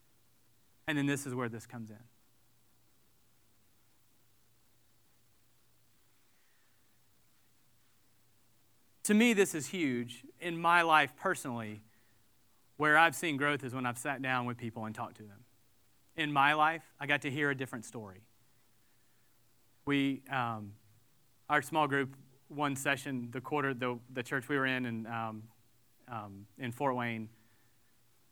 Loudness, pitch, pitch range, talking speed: -33 LUFS, 120 Hz, 115-140 Hz, 135 wpm